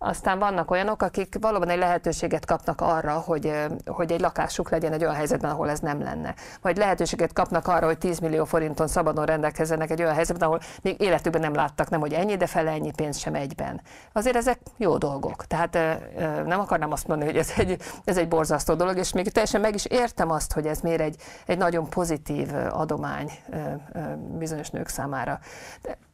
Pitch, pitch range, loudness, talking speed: 165 Hz, 160-180 Hz, -26 LUFS, 190 wpm